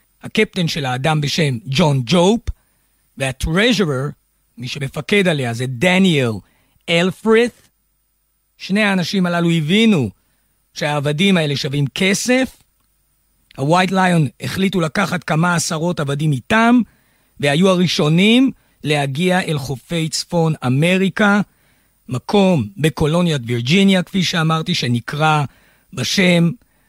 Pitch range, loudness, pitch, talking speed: 140-190 Hz, -16 LUFS, 165 Hz, 95 wpm